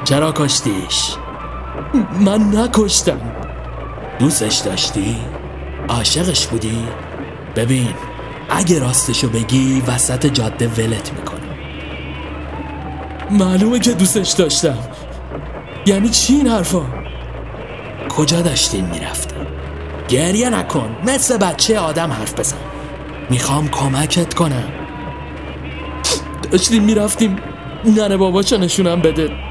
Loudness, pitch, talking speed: -15 LUFS, 140 Hz, 85 wpm